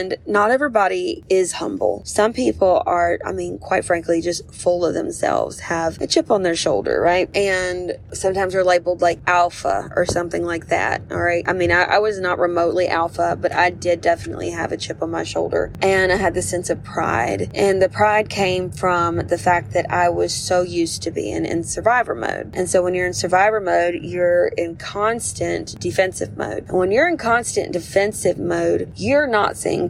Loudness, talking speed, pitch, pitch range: -19 LUFS, 200 wpm, 180 Hz, 170-195 Hz